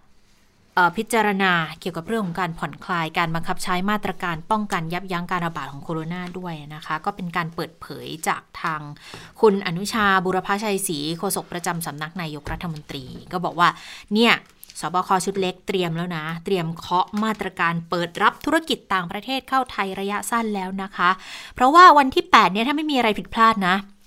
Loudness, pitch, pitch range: -21 LUFS, 185 Hz, 170-205 Hz